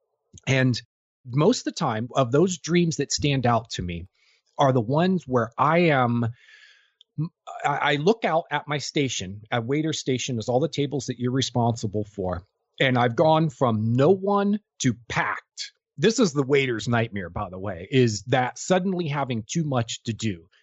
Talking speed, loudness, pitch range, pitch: 175 wpm, -24 LUFS, 115-160 Hz, 130 Hz